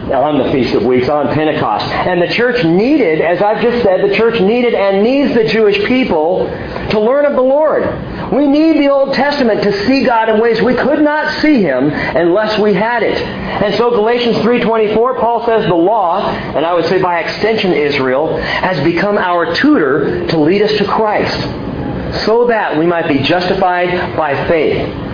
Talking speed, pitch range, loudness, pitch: 190 wpm, 180-245 Hz, -12 LUFS, 215 Hz